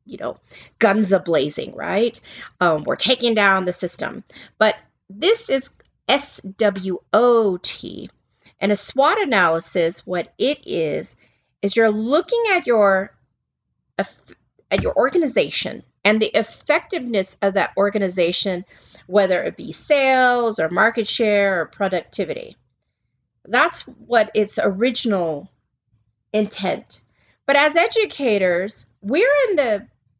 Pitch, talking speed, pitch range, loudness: 210 Hz, 115 wpm, 190-255 Hz, -19 LUFS